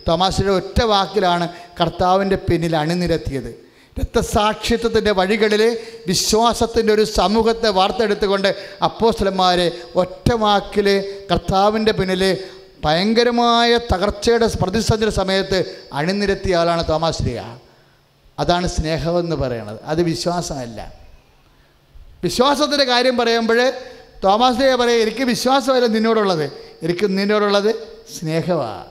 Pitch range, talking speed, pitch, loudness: 170-225 Hz, 85 wpm, 195 Hz, -18 LUFS